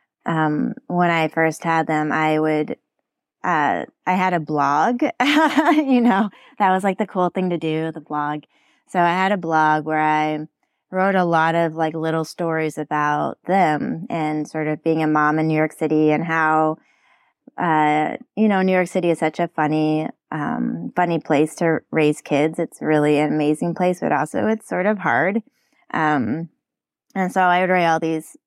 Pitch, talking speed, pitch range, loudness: 160 Hz, 185 wpm, 155-185 Hz, -20 LUFS